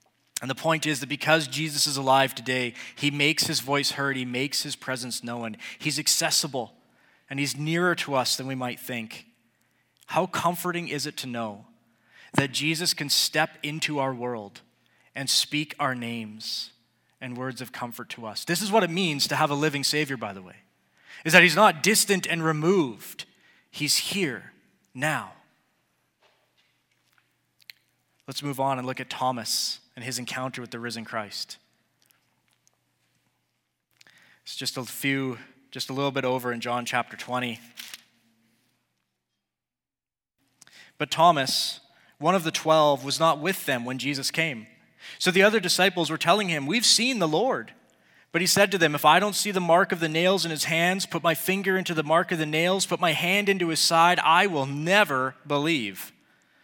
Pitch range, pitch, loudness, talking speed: 125-165 Hz, 145 Hz, -24 LUFS, 175 wpm